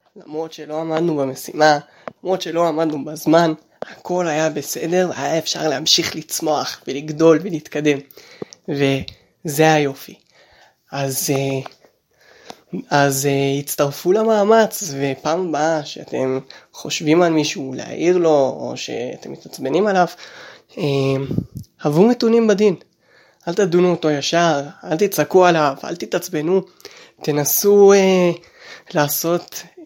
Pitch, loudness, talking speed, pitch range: 160 Hz, -18 LUFS, 100 wpm, 145-180 Hz